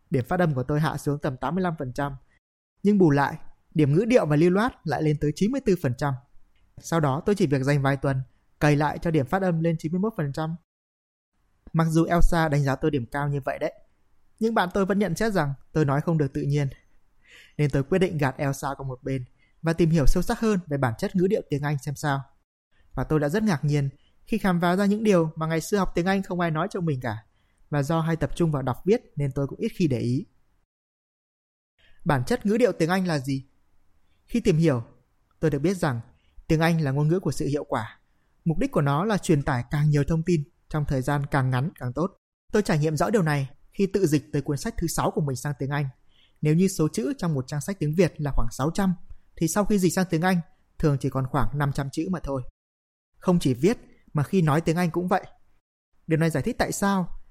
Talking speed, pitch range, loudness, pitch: 240 wpm, 140-180 Hz, -25 LUFS, 155 Hz